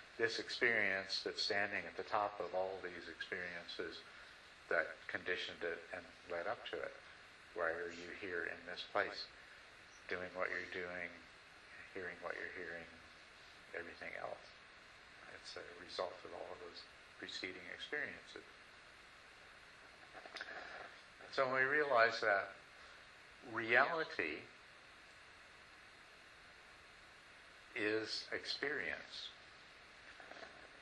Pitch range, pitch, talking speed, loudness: 85-105 Hz, 95 Hz, 105 wpm, -41 LUFS